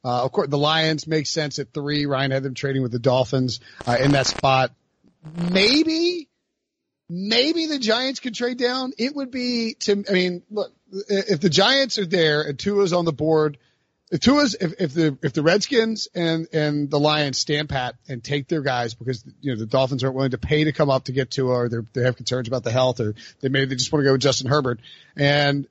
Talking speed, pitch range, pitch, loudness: 220 wpm, 135-200 Hz, 150 Hz, -21 LUFS